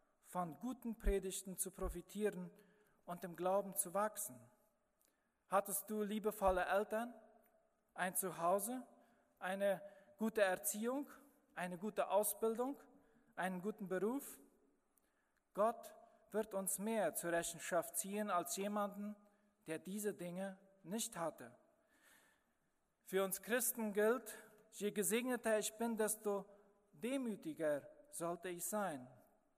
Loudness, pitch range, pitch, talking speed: -42 LUFS, 185-225 Hz, 205 Hz, 105 wpm